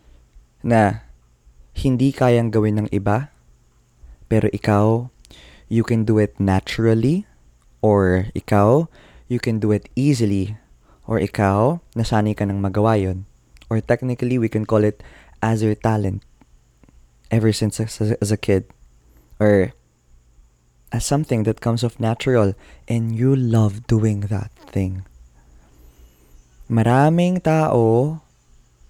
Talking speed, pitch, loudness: 120 wpm, 105 Hz, -19 LUFS